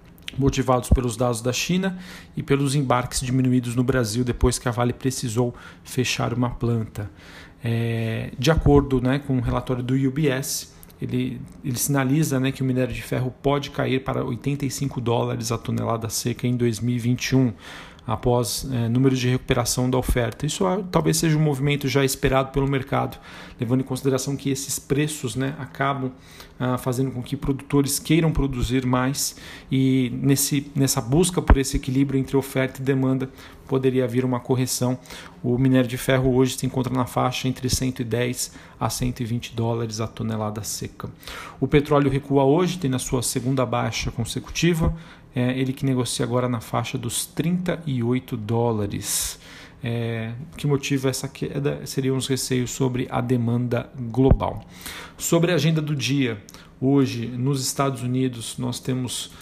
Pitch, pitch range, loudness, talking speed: 130 Hz, 120-135 Hz, -23 LUFS, 160 wpm